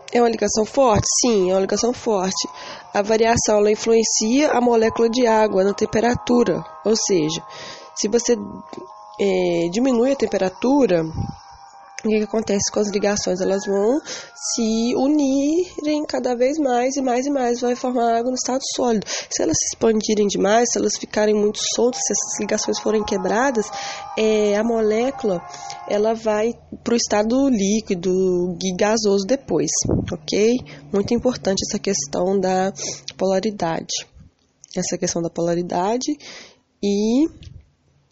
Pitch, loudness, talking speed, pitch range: 220 Hz, -20 LUFS, 140 wpm, 200-240 Hz